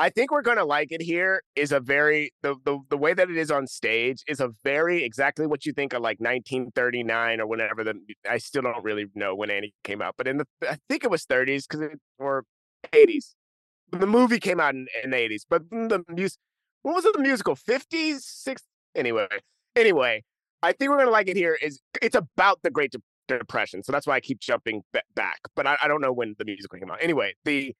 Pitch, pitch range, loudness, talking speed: 150 Hz, 125-195 Hz, -25 LUFS, 230 wpm